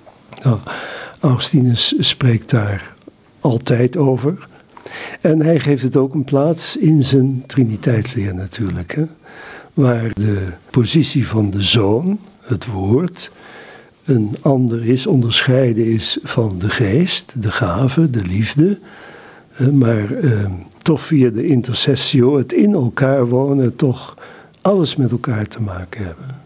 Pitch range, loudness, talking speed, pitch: 115-145 Hz, -16 LUFS, 125 wpm, 130 Hz